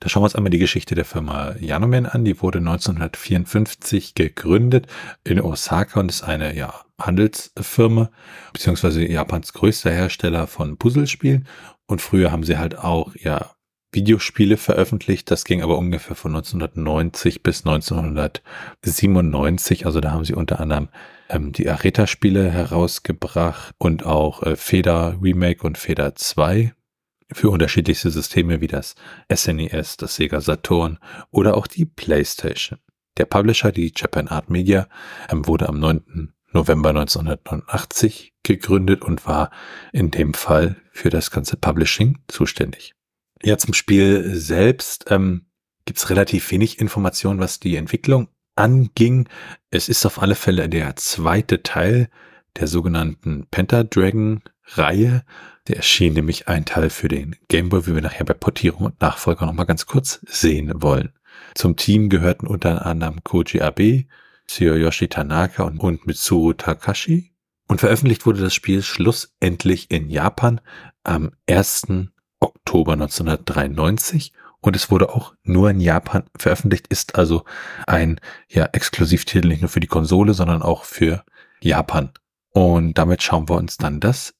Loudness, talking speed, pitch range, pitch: -19 LUFS, 140 wpm, 80-105 Hz, 90 Hz